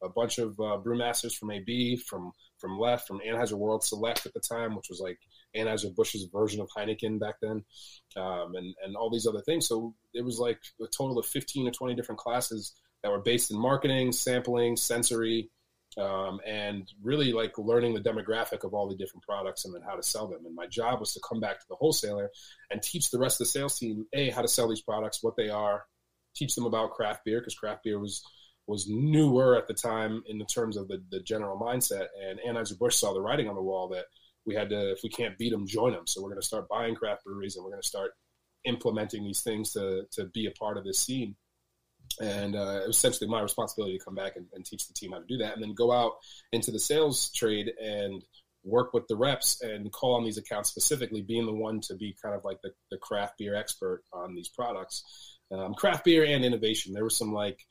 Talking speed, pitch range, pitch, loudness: 235 wpm, 100-120 Hz, 110 Hz, -30 LUFS